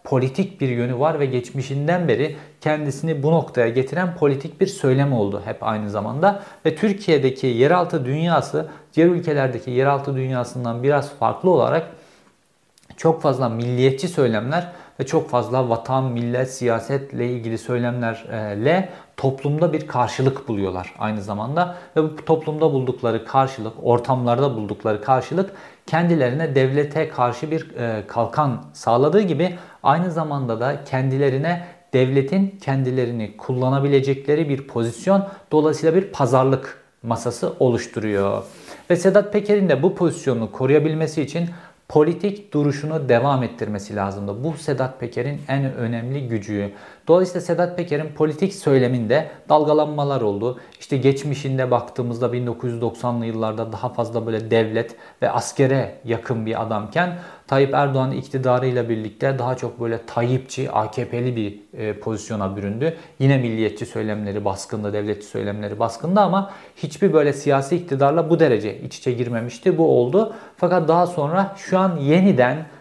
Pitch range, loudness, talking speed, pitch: 120-160 Hz, -21 LUFS, 125 wpm, 135 Hz